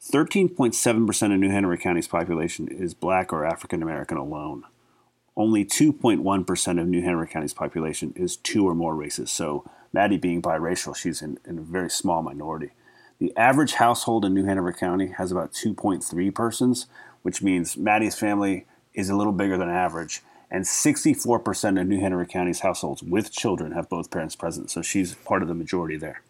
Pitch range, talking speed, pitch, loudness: 90-100 Hz, 175 wpm, 95 Hz, -24 LUFS